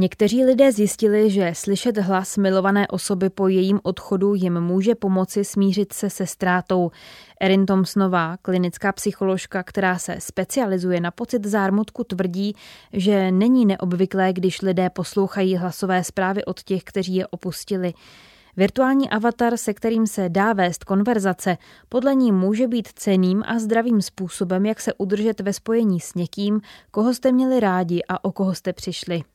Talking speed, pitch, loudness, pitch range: 150 wpm, 195 Hz, -21 LUFS, 185-210 Hz